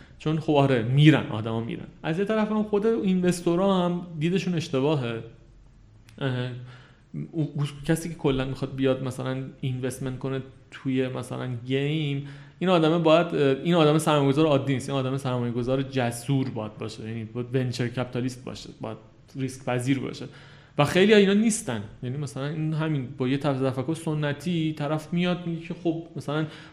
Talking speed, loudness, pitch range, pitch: 155 wpm, -26 LUFS, 130-160 Hz, 140 Hz